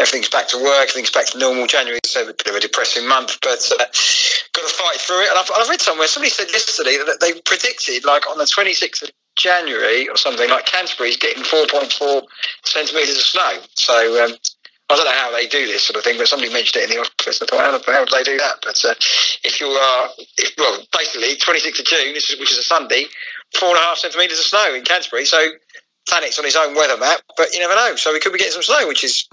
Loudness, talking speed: -15 LUFS, 250 wpm